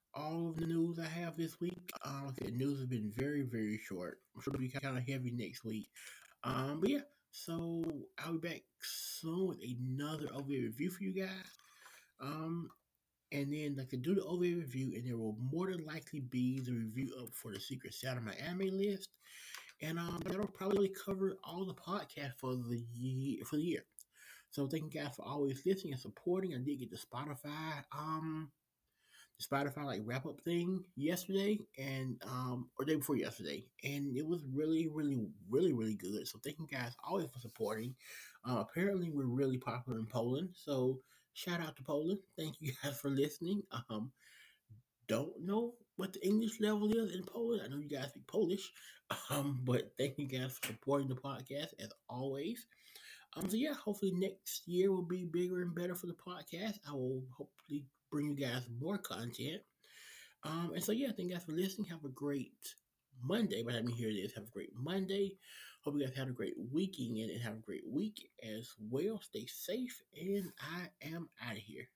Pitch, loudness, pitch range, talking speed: 145 Hz, -41 LUFS, 130-180 Hz, 195 wpm